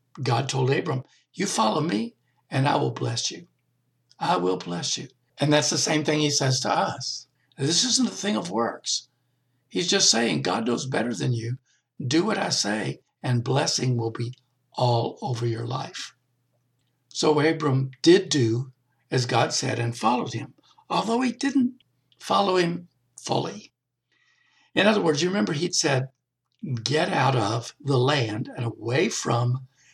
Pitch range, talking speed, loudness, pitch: 120-150 Hz, 160 wpm, -24 LUFS, 130 Hz